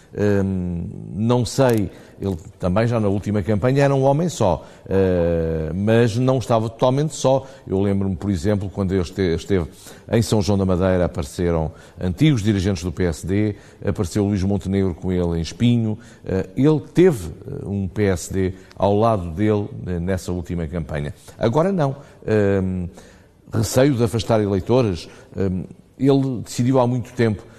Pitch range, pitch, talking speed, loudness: 95-120 Hz, 100 Hz, 145 wpm, -20 LUFS